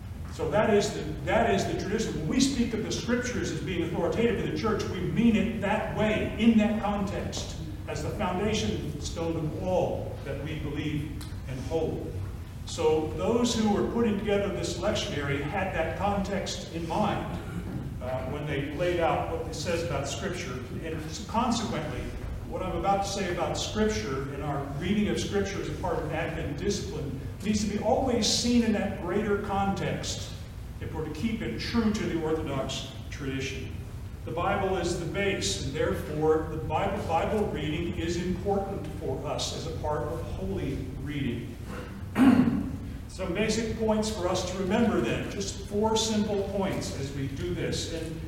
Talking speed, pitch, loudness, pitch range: 170 wpm, 170 Hz, -29 LUFS, 130-210 Hz